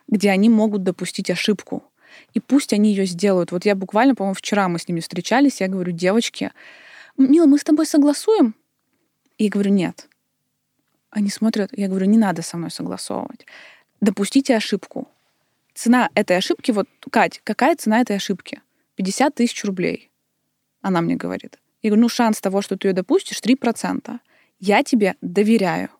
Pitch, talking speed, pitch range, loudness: 215 Hz, 160 wpm, 195-250 Hz, -19 LUFS